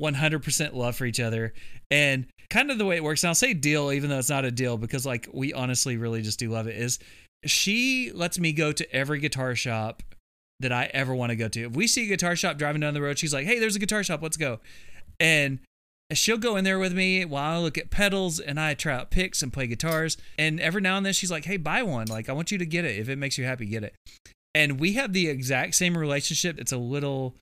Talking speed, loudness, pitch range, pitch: 265 wpm, -25 LUFS, 125-175 Hz, 150 Hz